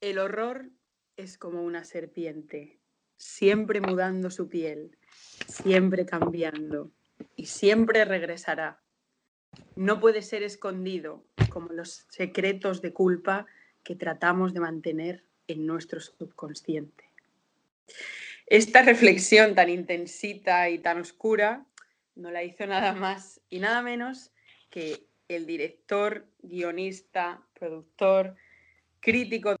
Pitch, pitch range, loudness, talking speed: 185 Hz, 170-205 Hz, -26 LUFS, 105 wpm